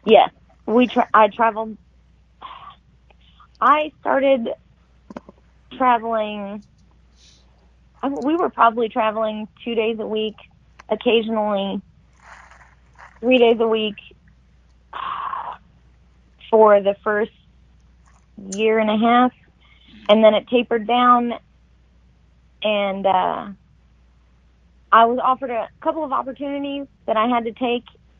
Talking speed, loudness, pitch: 100 wpm, -19 LUFS, 215 Hz